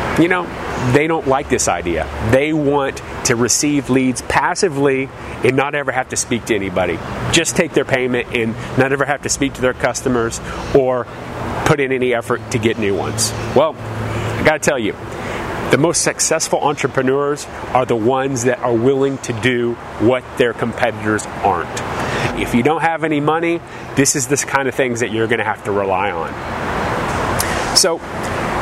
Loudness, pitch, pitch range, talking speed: -17 LUFS, 125 Hz, 115-140 Hz, 175 wpm